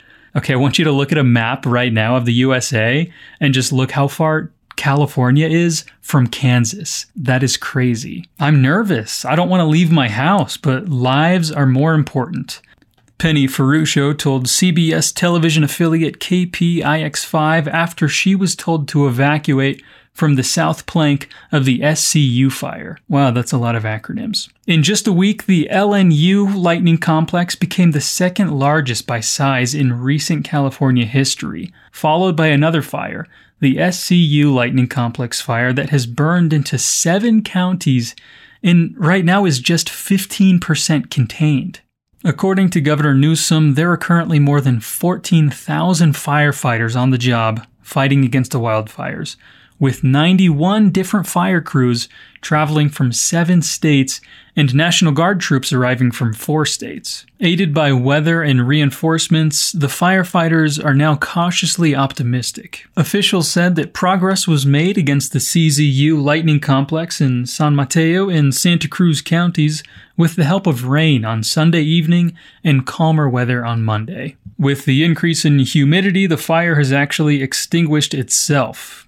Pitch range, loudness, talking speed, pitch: 135-170 Hz, -15 LUFS, 150 wpm, 150 Hz